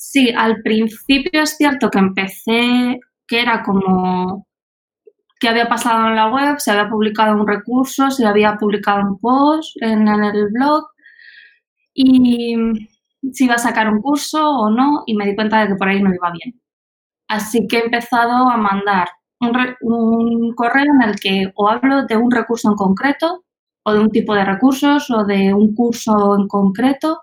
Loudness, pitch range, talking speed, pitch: -15 LUFS, 210-260 Hz, 180 wpm, 230 Hz